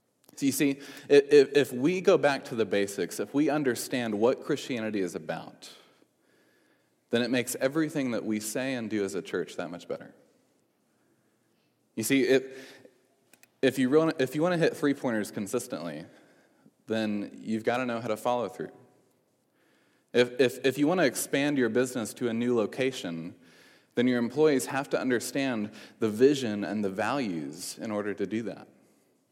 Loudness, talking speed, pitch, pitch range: -28 LUFS, 155 wpm, 125 Hz, 110-135 Hz